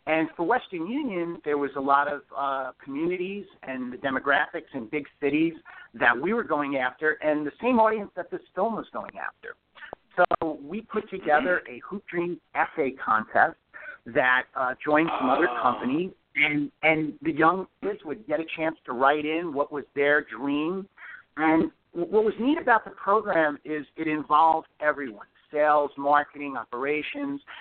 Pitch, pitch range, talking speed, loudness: 155 Hz, 145-190 Hz, 165 wpm, -26 LUFS